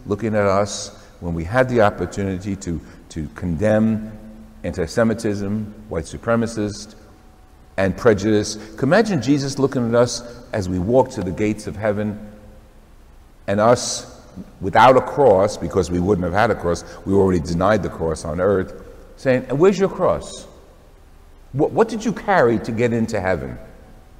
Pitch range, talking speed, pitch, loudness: 90-115 Hz, 160 wpm, 105 Hz, -19 LUFS